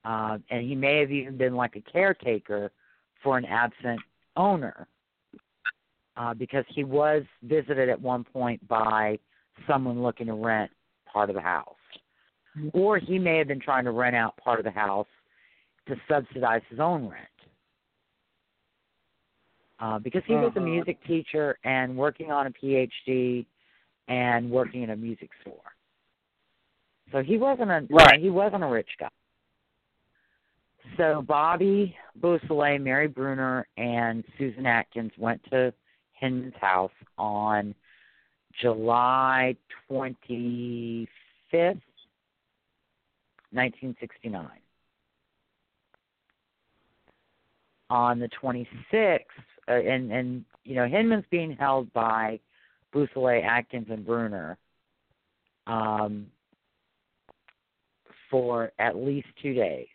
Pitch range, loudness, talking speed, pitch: 115-145 Hz, -26 LUFS, 115 wpm, 125 Hz